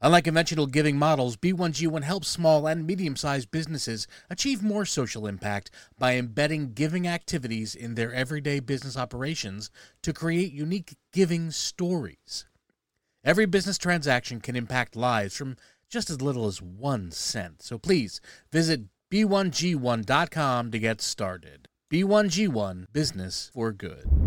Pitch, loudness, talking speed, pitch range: 145 Hz, -27 LUFS, 130 wpm, 115-170 Hz